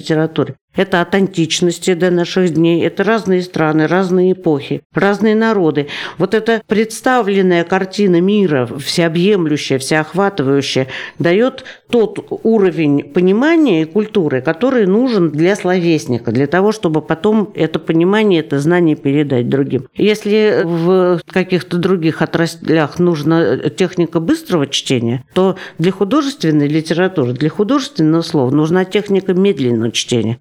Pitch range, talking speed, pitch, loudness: 155-195 Hz, 120 wpm, 175 Hz, -14 LUFS